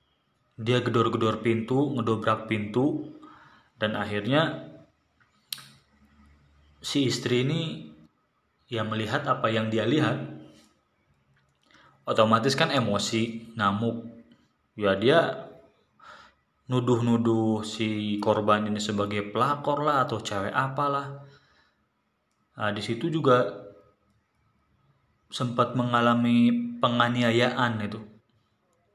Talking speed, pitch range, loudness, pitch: 85 wpm, 105-125 Hz, -26 LUFS, 115 Hz